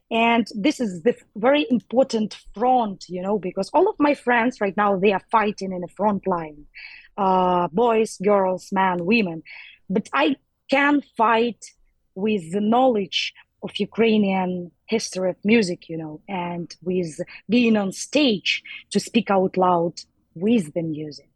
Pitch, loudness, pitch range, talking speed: 205 Hz, -22 LUFS, 185-230 Hz, 150 wpm